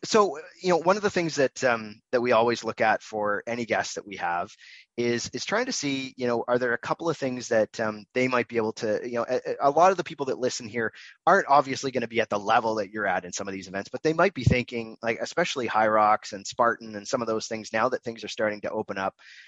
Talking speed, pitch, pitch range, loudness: 285 wpm, 120 Hz, 110-140 Hz, -26 LUFS